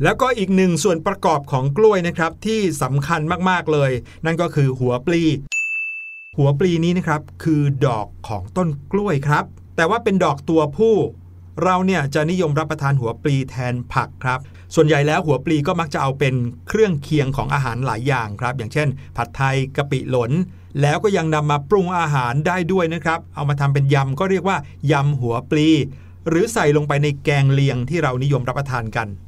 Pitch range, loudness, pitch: 130-170 Hz, -19 LUFS, 145 Hz